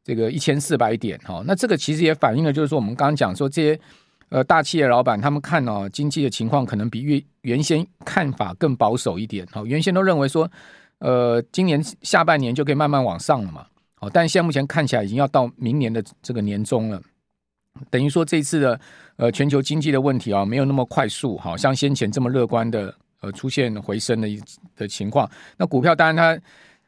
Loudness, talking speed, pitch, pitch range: -21 LUFS, 320 characters per minute, 135 Hz, 115-155 Hz